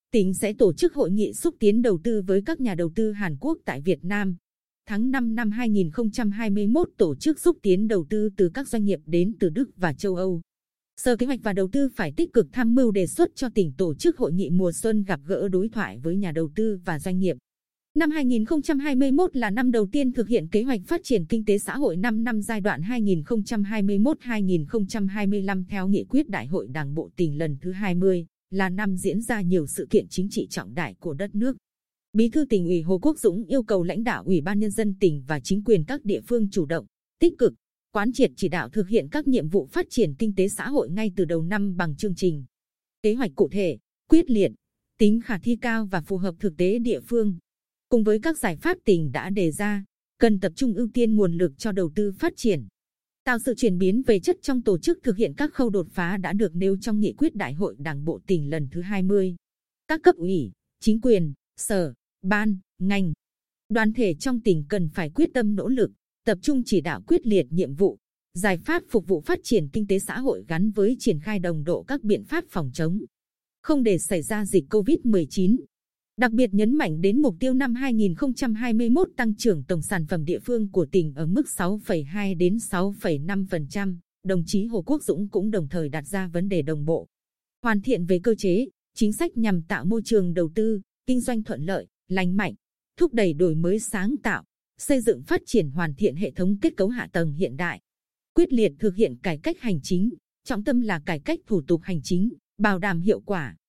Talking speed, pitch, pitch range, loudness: 220 wpm, 205 Hz, 185-235 Hz, -24 LUFS